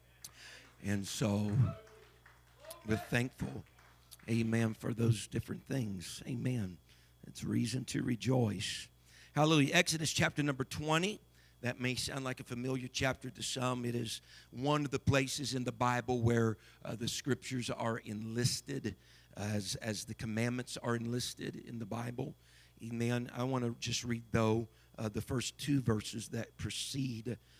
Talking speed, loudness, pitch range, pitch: 145 wpm, -36 LUFS, 110-130 Hz, 120 Hz